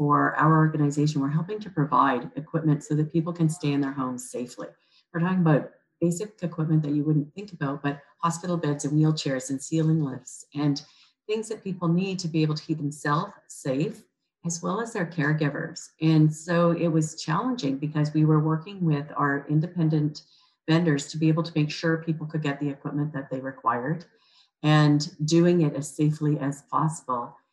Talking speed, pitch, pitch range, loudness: 185 wpm, 155 Hz, 145-170 Hz, -26 LUFS